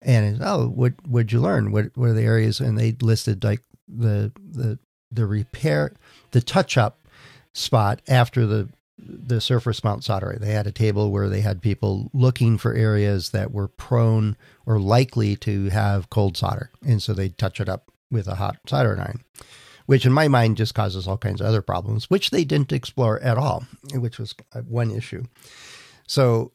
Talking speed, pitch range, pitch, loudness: 185 wpm, 105-125 Hz, 115 Hz, -22 LUFS